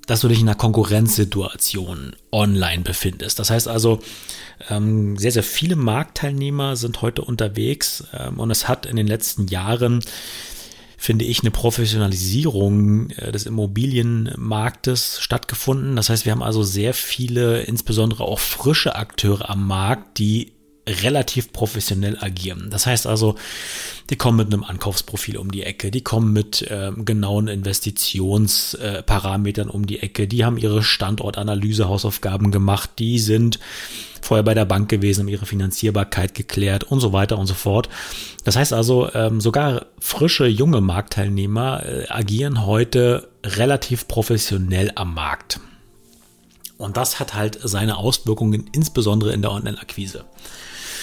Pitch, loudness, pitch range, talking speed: 110 Hz, -20 LUFS, 100-115 Hz, 140 wpm